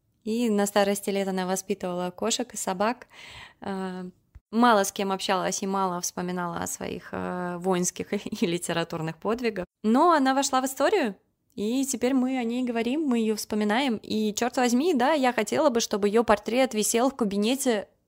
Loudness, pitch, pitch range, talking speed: -26 LUFS, 215 Hz, 195-245 Hz, 165 wpm